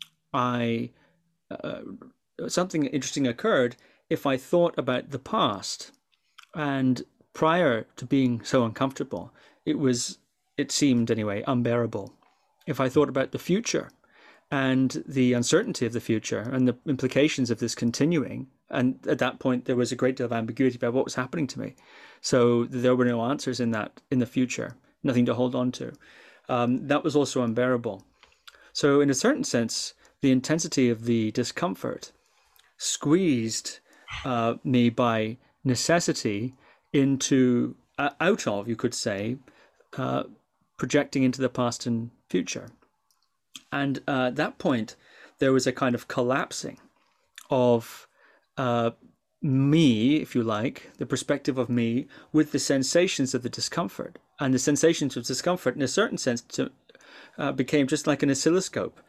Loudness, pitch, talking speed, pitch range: -26 LUFS, 130 Hz, 150 wpm, 120-145 Hz